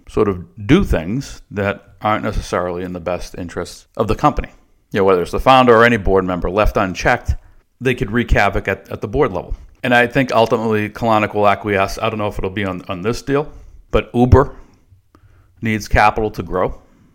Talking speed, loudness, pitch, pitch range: 205 wpm, -17 LUFS, 100 Hz, 95-115 Hz